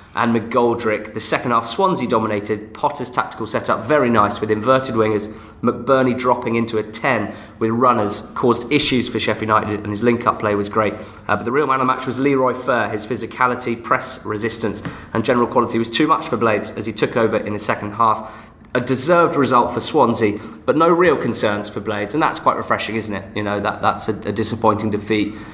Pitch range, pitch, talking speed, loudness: 105-125 Hz, 110 Hz, 210 wpm, -18 LUFS